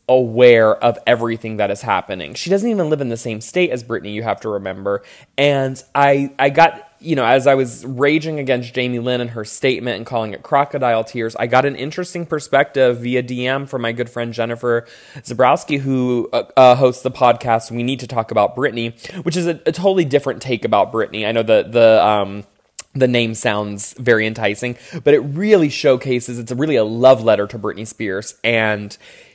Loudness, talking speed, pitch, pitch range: -17 LUFS, 200 wpm, 125 Hz, 115-140 Hz